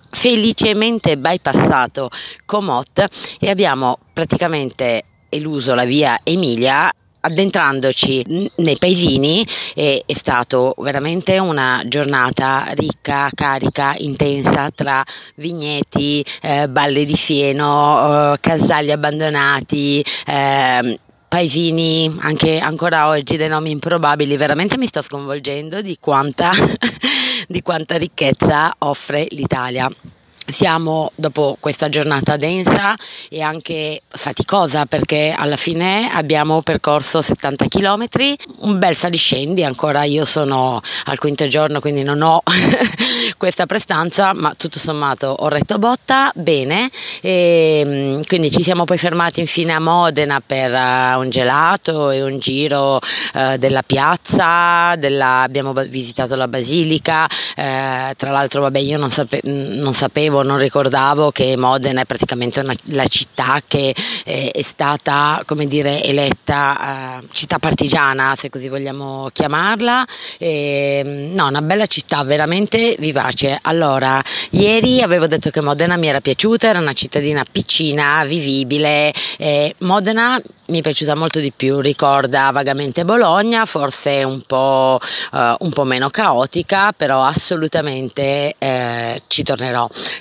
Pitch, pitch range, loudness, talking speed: 150 Hz, 135-170 Hz, -15 LUFS, 125 wpm